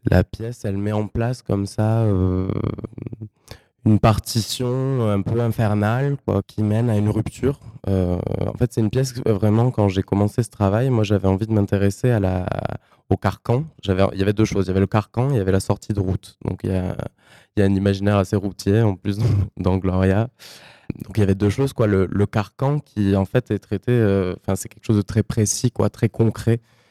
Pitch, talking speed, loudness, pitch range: 105 Hz, 225 wpm, -21 LUFS, 100-115 Hz